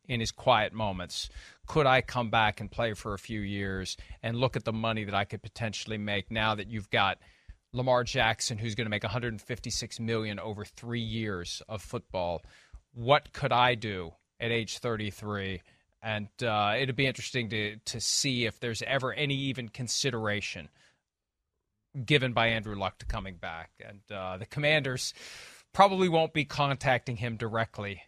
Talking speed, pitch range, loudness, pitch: 170 wpm, 100-125 Hz, -30 LUFS, 115 Hz